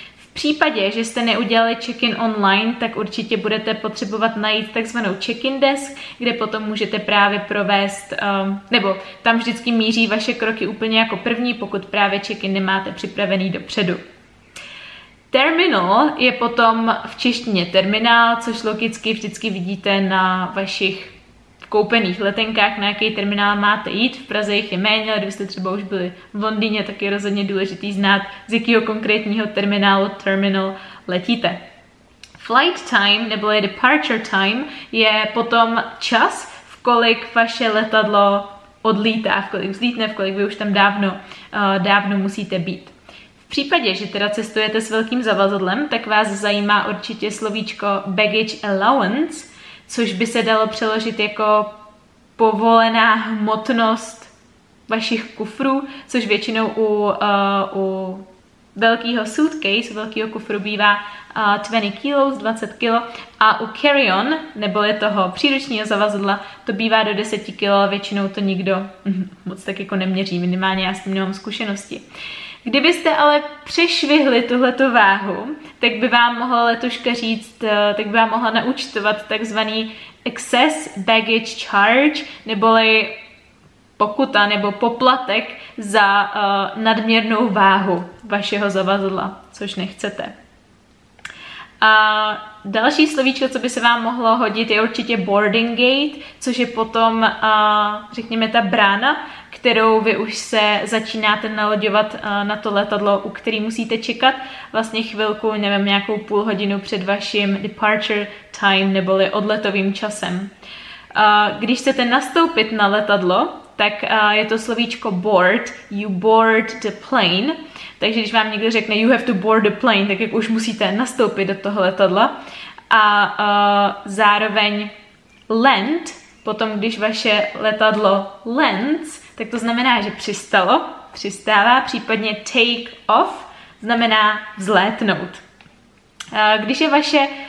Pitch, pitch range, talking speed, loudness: 215 Hz, 200-230 Hz, 135 wpm, -17 LUFS